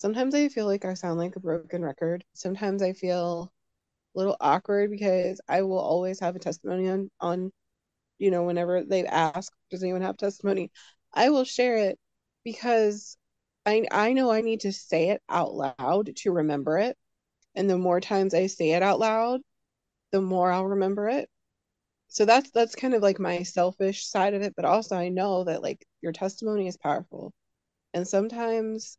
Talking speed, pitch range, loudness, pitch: 185 wpm, 180-210 Hz, -26 LUFS, 190 Hz